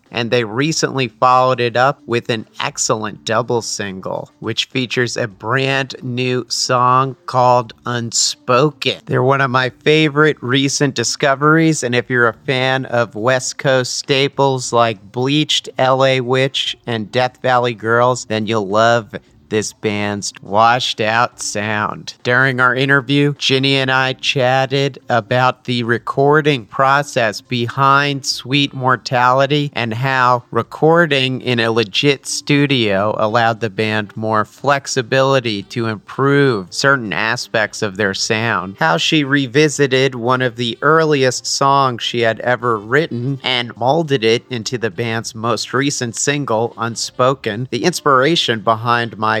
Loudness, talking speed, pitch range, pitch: -16 LUFS, 135 wpm, 115-135 Hz, 125 Hz